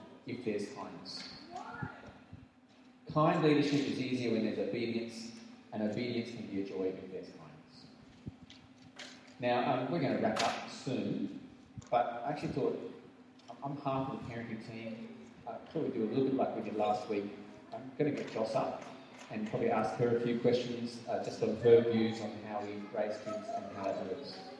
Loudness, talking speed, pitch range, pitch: -35 LUFS, 185 wpm, 110-135 Hz, 115 Hz